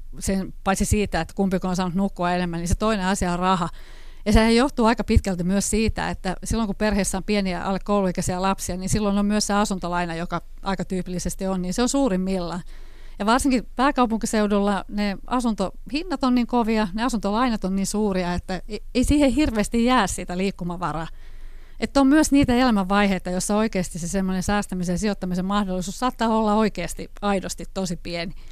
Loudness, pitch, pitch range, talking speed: -23 LUFS, 195 Hz, 185-225 Hz, 175 wpm